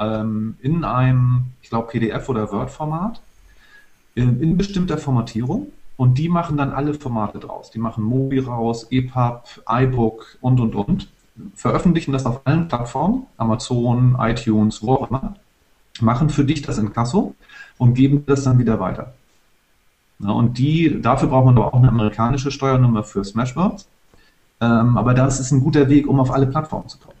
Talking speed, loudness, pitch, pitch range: 160 wpm, -19 LUFS, 125 Hz, 115-145 Hz